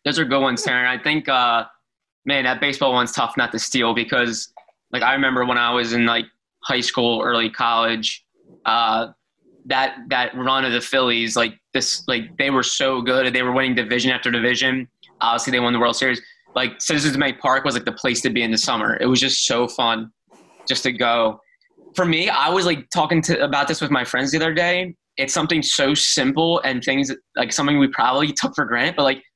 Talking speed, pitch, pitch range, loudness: 215 wpm, 130 Hz, 120-145 Hz, -19 LUFS